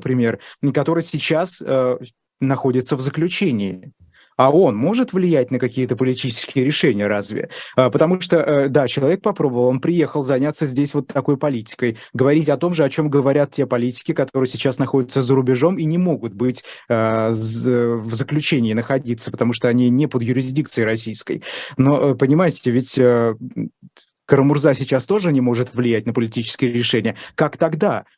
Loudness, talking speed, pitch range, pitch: -18 LUFS, 160 wpm, 120-150 Hz, 135 Hz